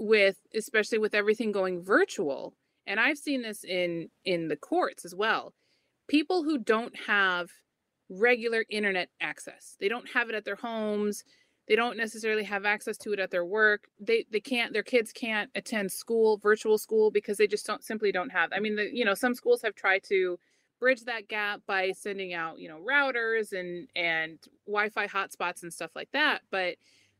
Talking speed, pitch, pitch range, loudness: 185 wpm, 215 Hz, 195-230 Hz, -29 LUFS